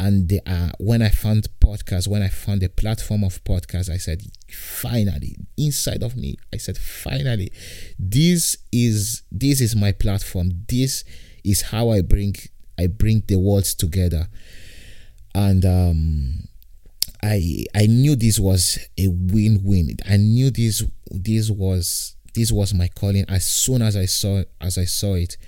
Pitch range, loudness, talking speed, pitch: 90-110 Hz, -20 LUFS, 155 wpm, 100 Hz